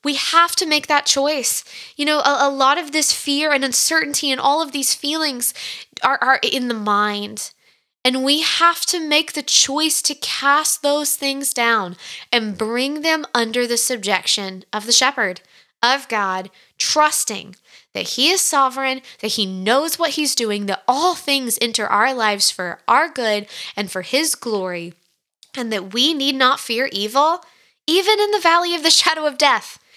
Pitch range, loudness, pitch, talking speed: 225-300 Hz, -17 LUFS, 270 Hz, 180 wpm